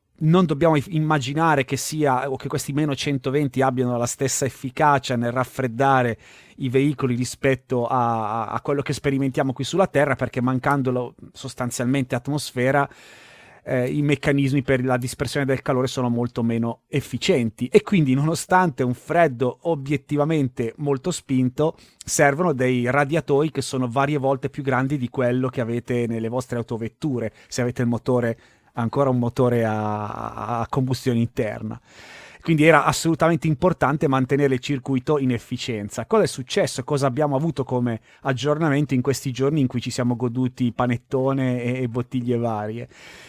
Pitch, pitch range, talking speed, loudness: 130 Hz, 125-145 Hz, 150 wpm, -22 LUFS